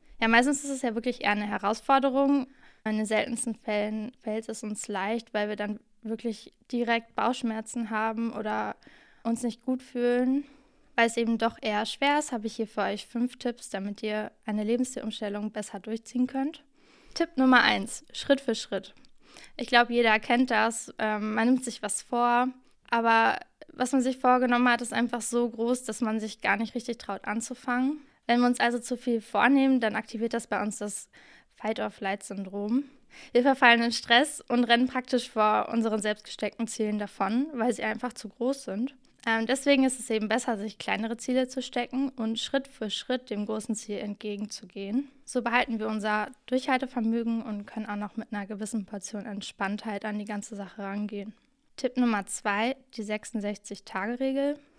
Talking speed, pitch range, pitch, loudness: 175 wpm, 215-250 Hz, 230 Hz, -28 LUFS